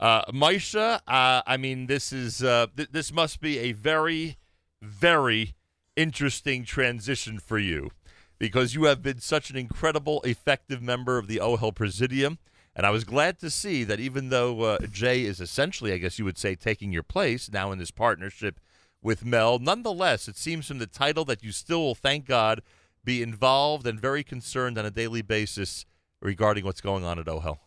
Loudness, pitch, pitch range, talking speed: -26 LUFS, 120 Hz, 105-140 Hz, 185 wpm